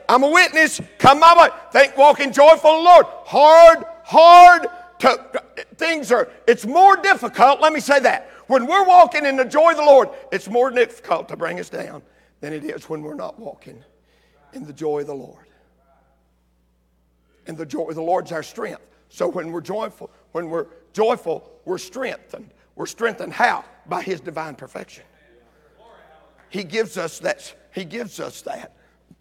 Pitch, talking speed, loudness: 245 Hz, 175 wpm, -14 LUFS